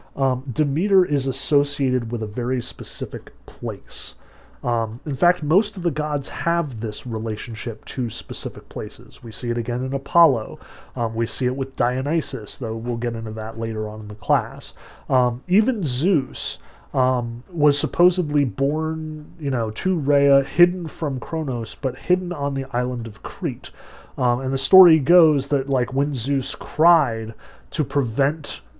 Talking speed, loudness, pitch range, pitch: 160 wpm, -22 LUFS, 120-155 Hz, 135 Hz